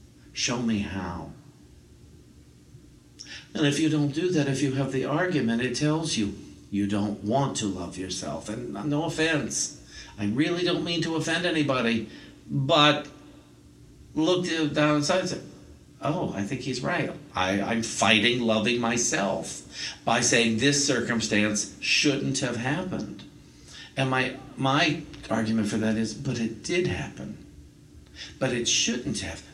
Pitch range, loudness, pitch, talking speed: 105-150 Hz, -26 LUFS, 125 Hz, 145 wpm